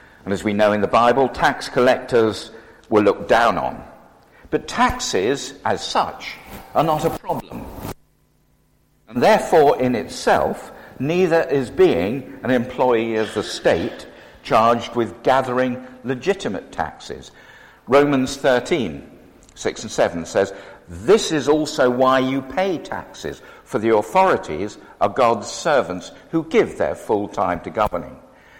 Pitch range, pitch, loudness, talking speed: 115-150 Hz, 130 Hz, -19 LUFS, 135 wpm